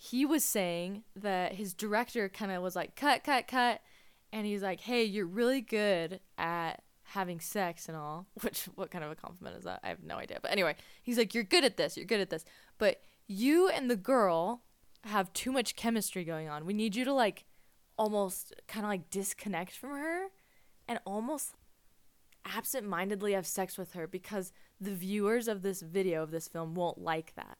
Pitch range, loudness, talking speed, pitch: 180-230 Hz, -34 LUFS, 200 wpm, 200 Hz